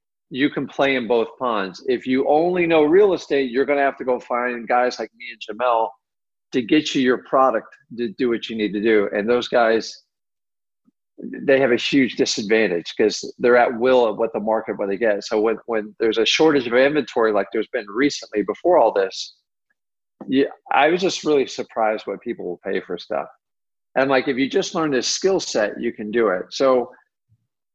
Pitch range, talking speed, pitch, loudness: 115-145 Hz, 205 wpm, 125 Hz, -20 LUFS